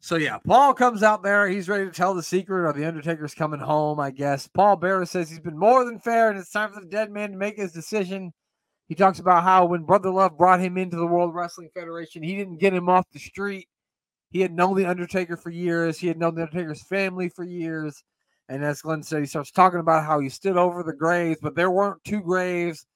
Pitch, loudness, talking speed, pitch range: 180 Hz, -23 LUFS, 245 wpm, 165-195 Hz